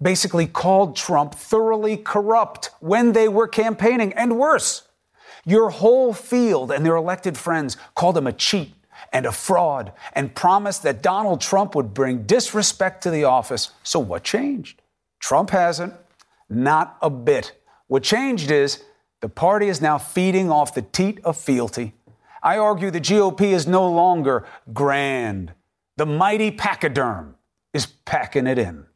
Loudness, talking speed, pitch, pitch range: -20 LUFS, 150 wpm, 185 Hz, 145-215 Hz